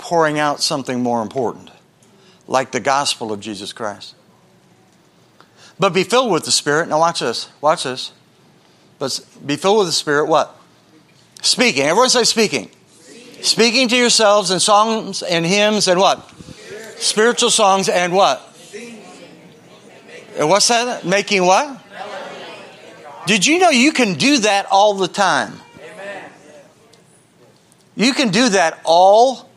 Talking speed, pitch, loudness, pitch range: 135 wpm, 195 Hz, -15 LUFS, 155-225 Hz